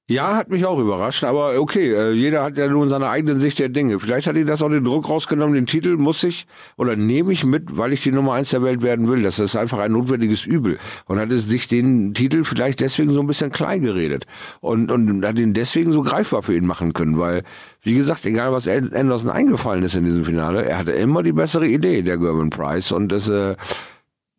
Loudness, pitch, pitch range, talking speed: -19 LUFS, 125 Hz, 105-145 Hz, 230 wpm